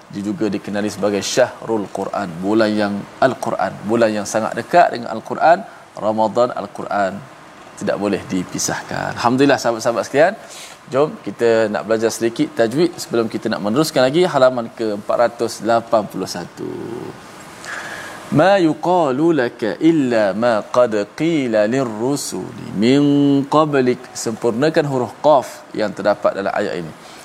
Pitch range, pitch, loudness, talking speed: 110-140 Hz, 115 Hz, -18 LUFS, 120 wpm